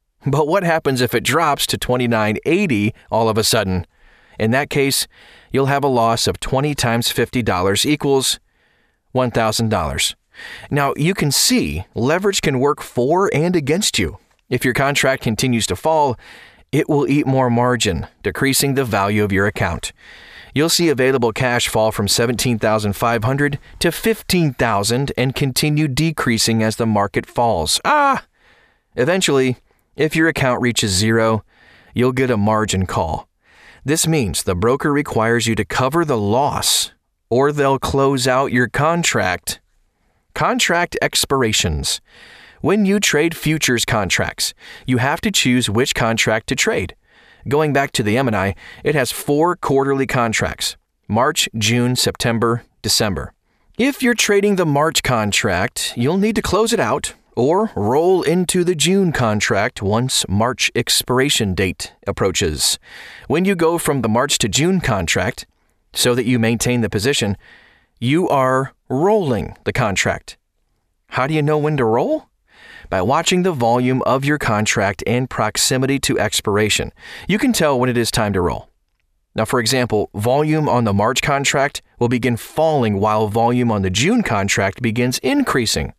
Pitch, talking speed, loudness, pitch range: 125 Hz, 155 wpm, -17 LUFS, 110-150 Hz